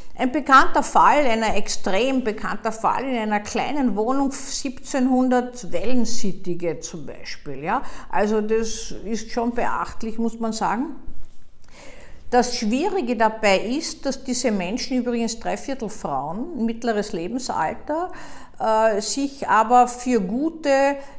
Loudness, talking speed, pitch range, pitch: -22 LUFS, 115 wpm, 215-265 Hz, 240 Hz